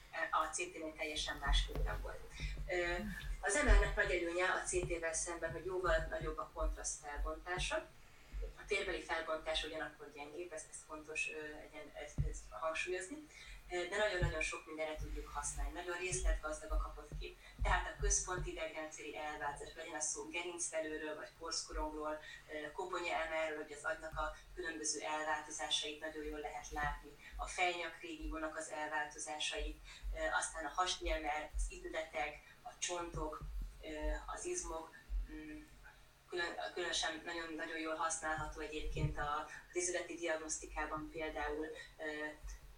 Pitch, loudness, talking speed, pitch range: 155 Hz, -41 LUFS, 125 wpm, 150-170 Hz